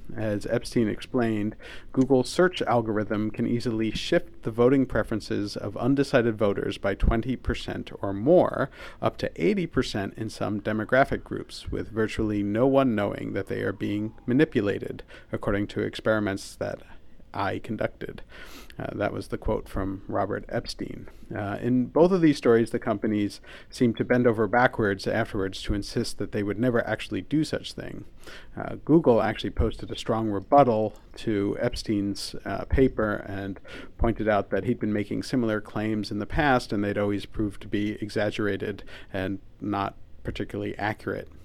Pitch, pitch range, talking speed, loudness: 110 Hz, 105-120 Hz, 155 wpm, -26 LUFS